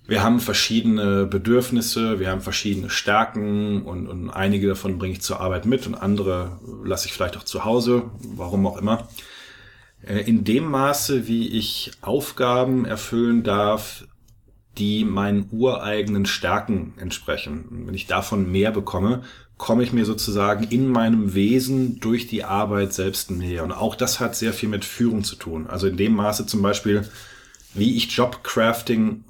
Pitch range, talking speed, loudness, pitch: 100-115 Hz, 160 wpm, -22 LUFS, 110 Hz